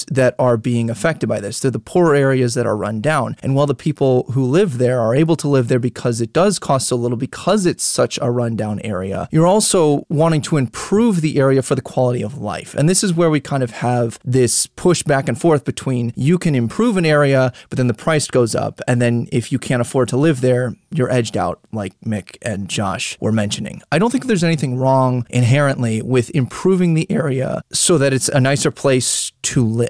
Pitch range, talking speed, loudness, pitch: 120-155 Hz, 225 wpm, -17 LUFS, 130 Hz